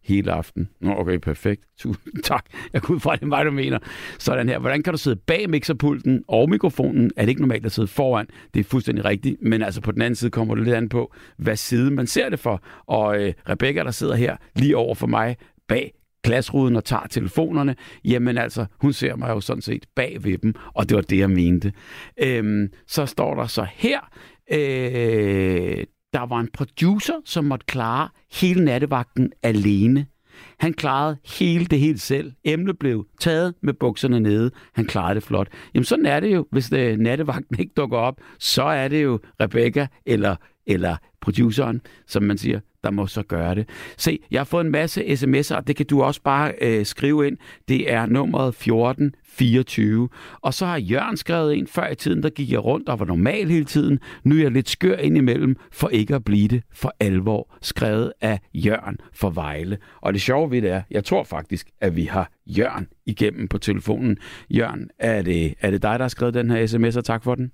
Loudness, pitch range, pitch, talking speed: -22 LUFS, 105-140 Hz, 120 Hz, 205 wpm